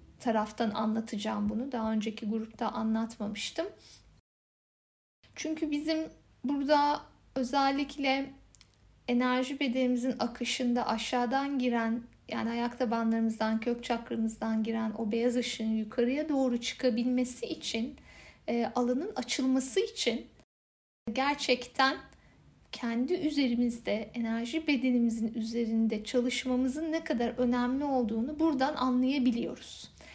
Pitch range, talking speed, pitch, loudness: 225-265 Hz, 90 wpm, 245 Hz, -31 LUFS